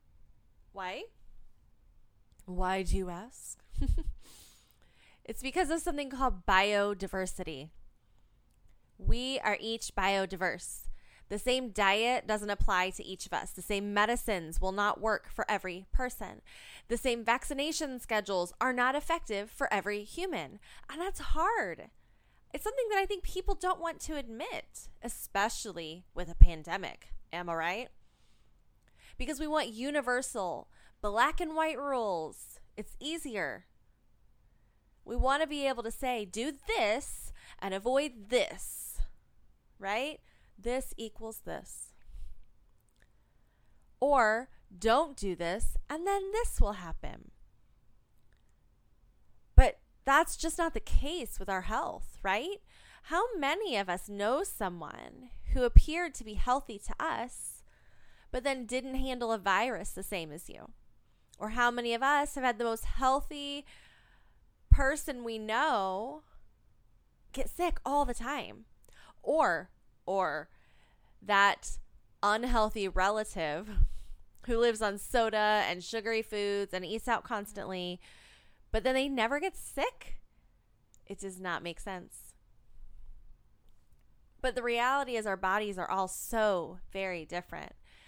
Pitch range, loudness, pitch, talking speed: 190-270 Hz, -33 LUFS, 225 Hz, 125 wpm